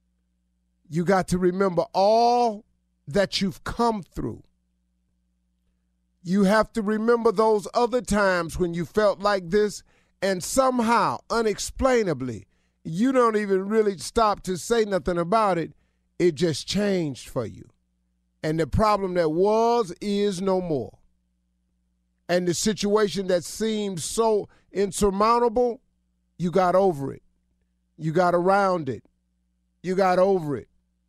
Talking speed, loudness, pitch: 125 wpm, -23 LUFS, 180 Hz